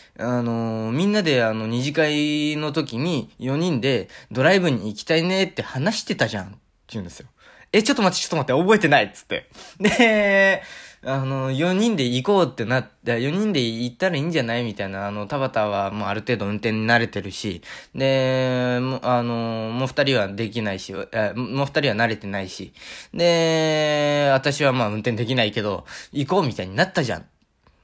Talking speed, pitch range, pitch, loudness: 365 characters per minute, 115-160 Hz, 130 Hz, -21 LUFS